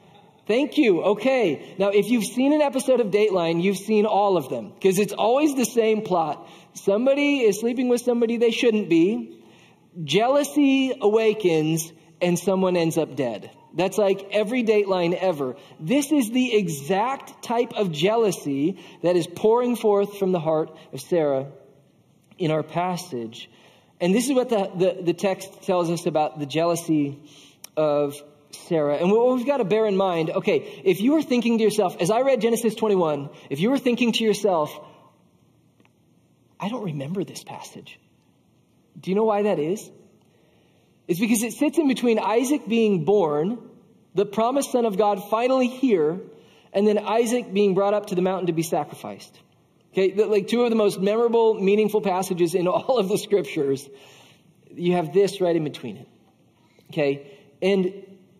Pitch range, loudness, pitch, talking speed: 170-230 Hz, -22 LUFS, 200 Hz, 170 wpm